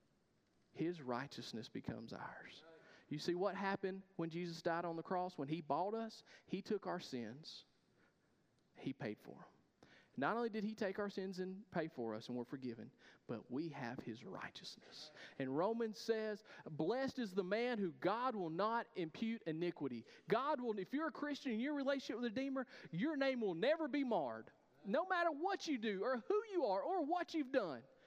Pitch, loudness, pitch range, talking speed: 205 Hz, -43 LUFS, 170-260 Hz, 195 wpm